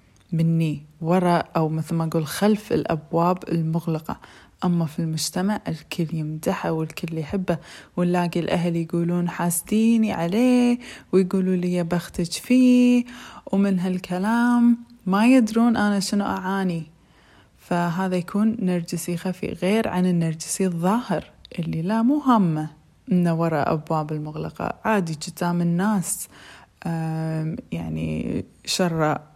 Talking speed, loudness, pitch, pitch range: 110 wpm, -23 LUFS, 175 Hz, 165-205 Hz